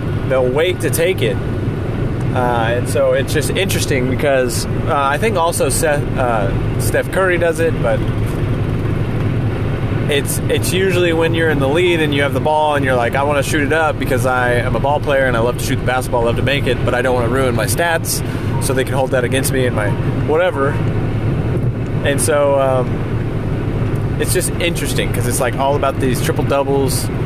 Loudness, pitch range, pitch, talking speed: -16 LUFS, 120-140 Hz, 130 Hz, 205 wpm